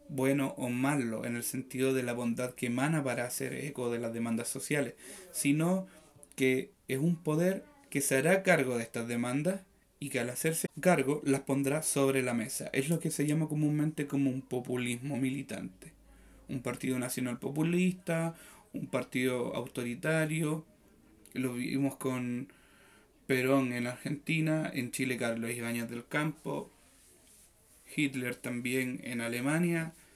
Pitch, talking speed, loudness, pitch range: 135 Hz, 145 wpm, -33 LUFS, 125-150 Hz